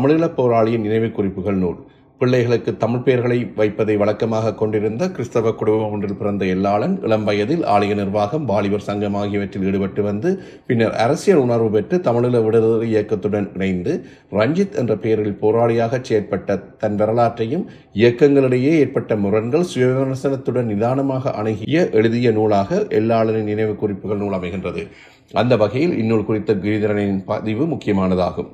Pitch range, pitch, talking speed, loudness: 105-120 Hz, 110 Hz, 125 wpm, -18 LUFS